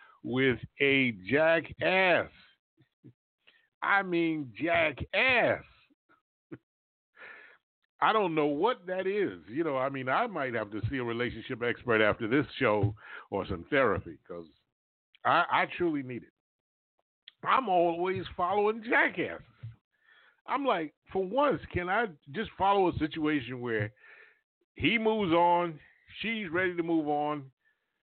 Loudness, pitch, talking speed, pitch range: -29 LUFS, 165 Hz, 125 wpm, 130-210 Hz